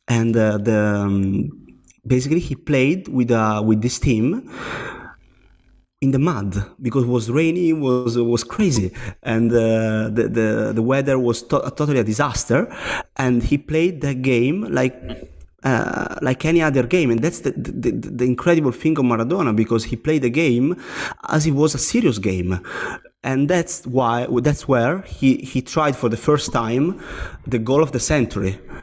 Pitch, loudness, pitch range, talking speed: 125 Hz, -20 LUFS, 115-145 Hz, 175 wpm